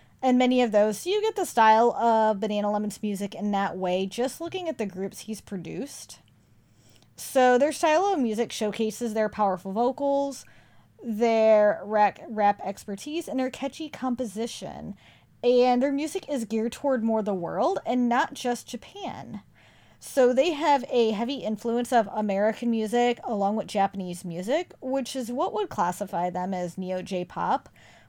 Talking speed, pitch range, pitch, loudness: 160 wpm, 205-260 Hz, 225 Hz, -26 LUFS